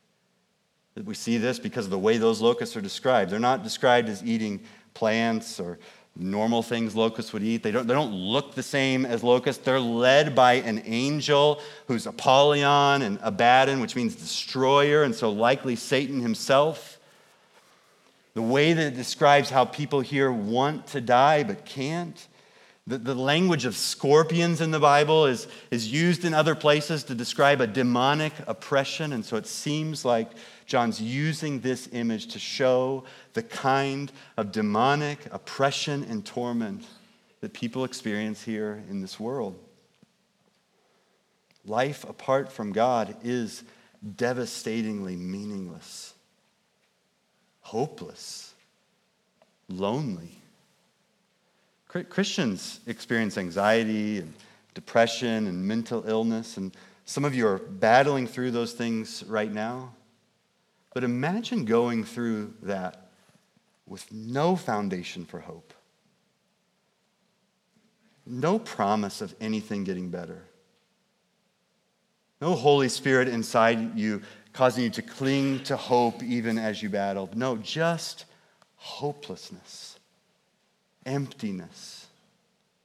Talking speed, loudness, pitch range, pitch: 120 wpm, -25 LUFS, 115-155 Hz, 130 Hz